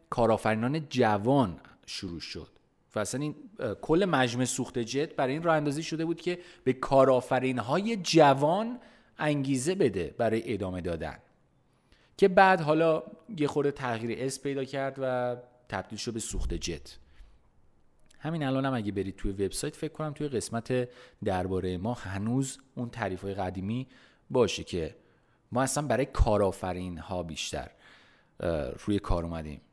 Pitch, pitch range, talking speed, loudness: 125 Hz, 100-145 Hz, 145 wpm, -29 LUFS